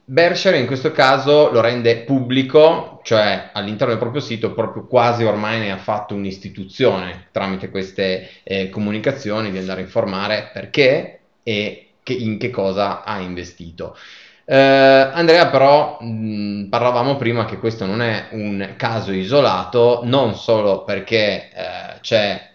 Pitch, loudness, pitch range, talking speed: 115 Hz, -17 LUFS, 100-135 Hz, 140 wpm